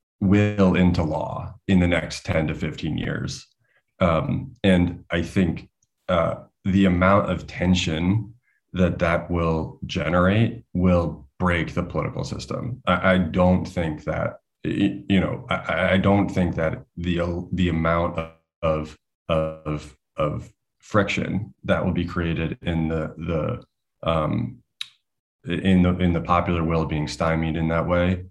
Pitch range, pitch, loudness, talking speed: 80-90 Hz, 85 Hz, -23 LUFS, 140 wpm